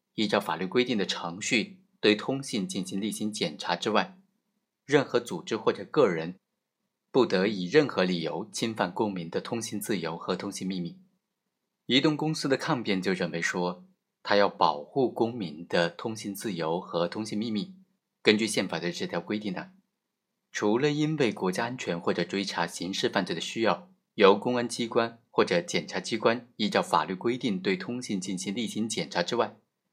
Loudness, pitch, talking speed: -28 LUFS, 120 Hz, 265 characters per minute